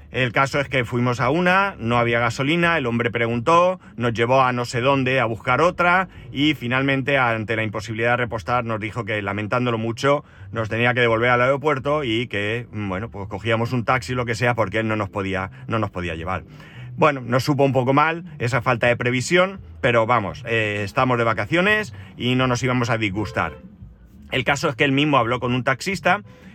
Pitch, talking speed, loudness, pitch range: 125 Hz, 205 wpm, -20 LUFS, 115-135 Hz